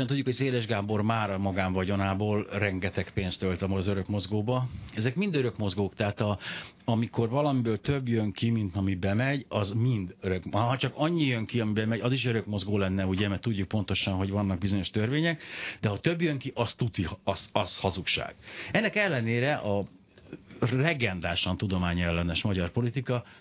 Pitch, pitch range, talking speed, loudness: 105 Hz, 95-125 Hz, 170 wpm, -29 LUFS